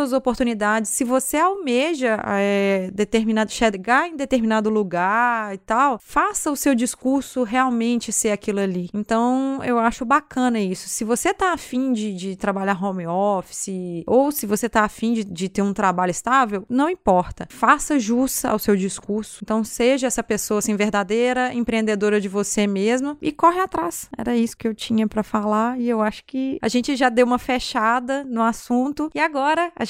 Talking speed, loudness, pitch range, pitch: 175 wpm, -21 LUFS, 210-260 Hz, 230 Hz